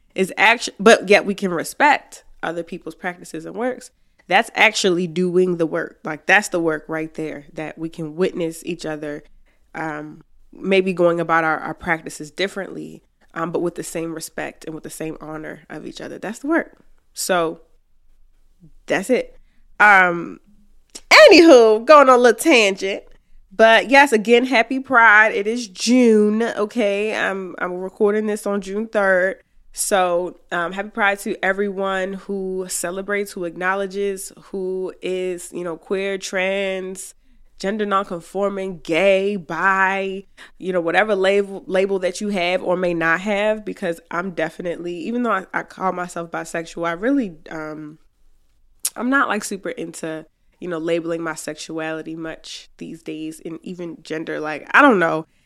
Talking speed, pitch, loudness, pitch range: 155 wpm, 185 Hz, -18 LUFS, 165-205 Hz